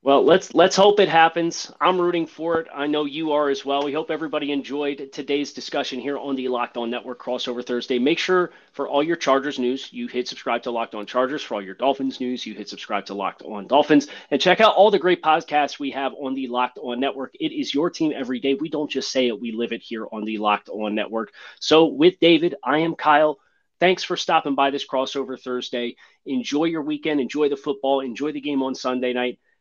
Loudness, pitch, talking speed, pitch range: -22 LUFS, 140 Hz, 235 wpm, 125-155 Hz